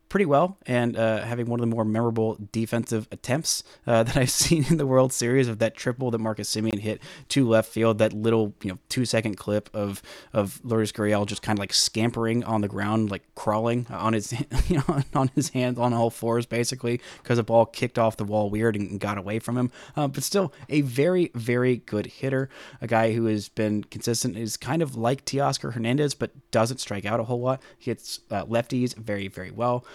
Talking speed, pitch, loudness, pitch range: 220 wpm, 115 Hz, -25 LUFS, 110-130 Hz